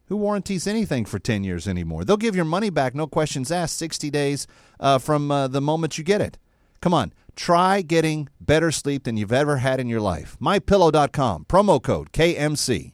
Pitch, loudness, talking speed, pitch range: 150 Hz, -22 LUFS, 195 wpm, 130-170 Hz